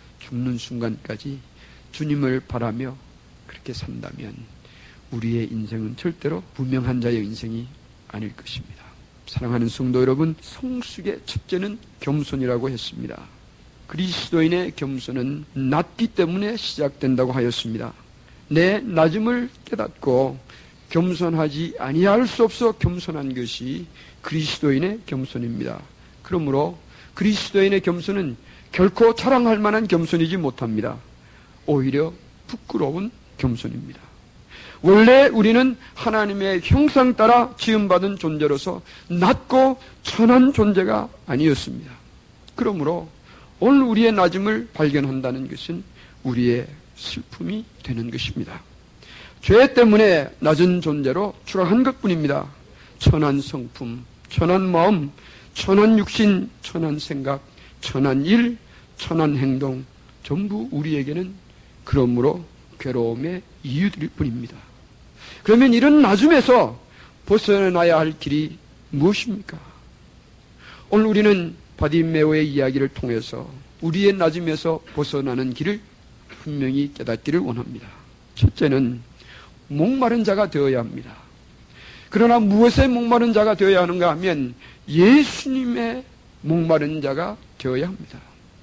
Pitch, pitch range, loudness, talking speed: 155 Hz, 130-200 Hz, -20 LUFS, 270 characters per minute